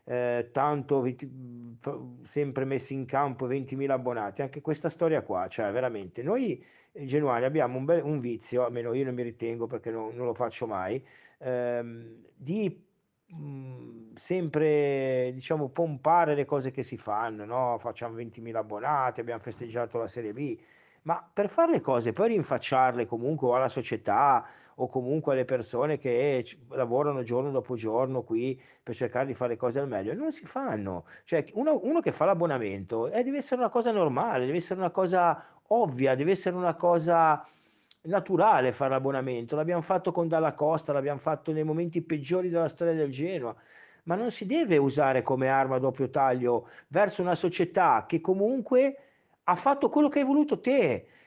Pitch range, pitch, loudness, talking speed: 125-170 Hz, 140 Hz, -28 LUFS, 165 wpm